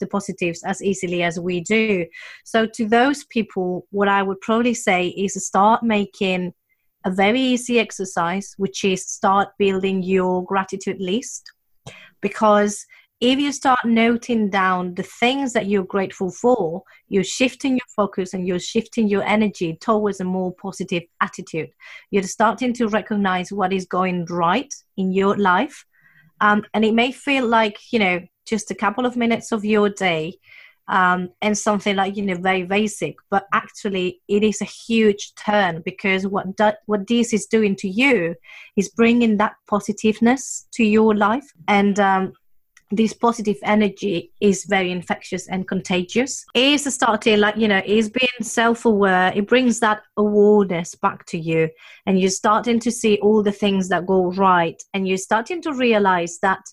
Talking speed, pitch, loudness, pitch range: 165 wpm, 205 Hz, -20 LUFS, 190-225 Hz